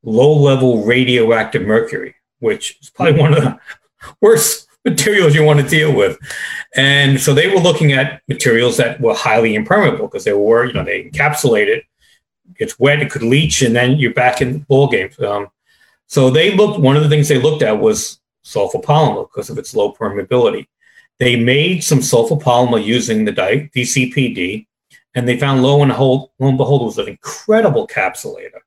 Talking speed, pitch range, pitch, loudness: 185 wpm, 125-210 Hz, 140 Hz, -13 LUFS